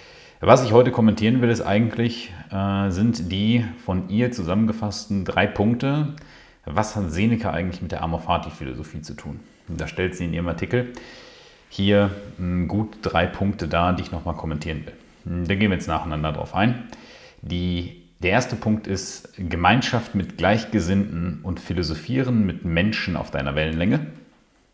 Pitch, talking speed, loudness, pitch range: 95 Hz, 155 wpm, -23 LUFS, 85-110 Hz